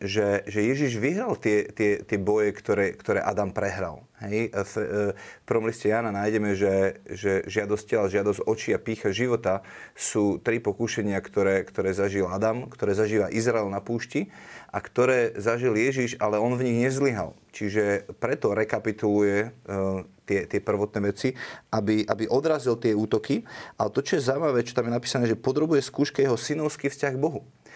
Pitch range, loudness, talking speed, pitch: 100-120 Hz, -26 LUFS, 165 wpm, 110 Hz